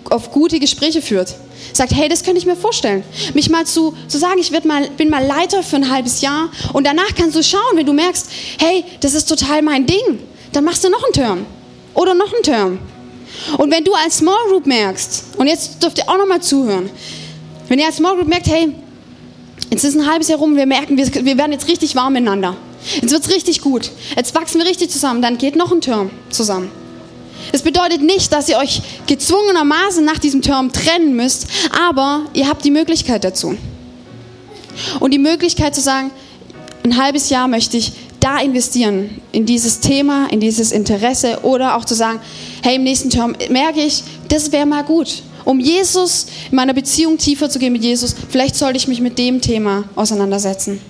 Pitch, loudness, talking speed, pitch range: 290 Hz, -14 LUFS, 200 wpm, 250-325 Hz